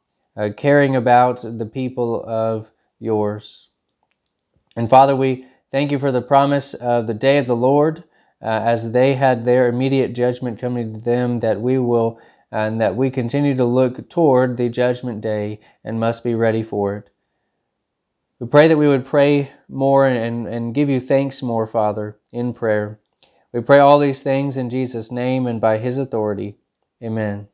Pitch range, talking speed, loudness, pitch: 115-135 Hz, 175 wpm, -18 LUFS, 125 Hz